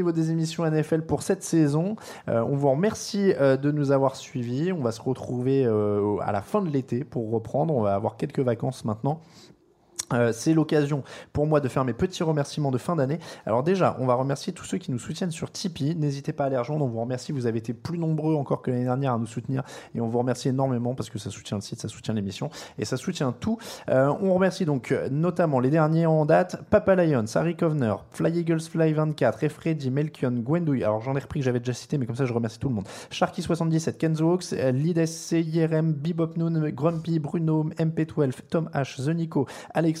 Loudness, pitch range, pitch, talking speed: -26 LUFS, 125-165 Hz, 145 Hz, 220 wpm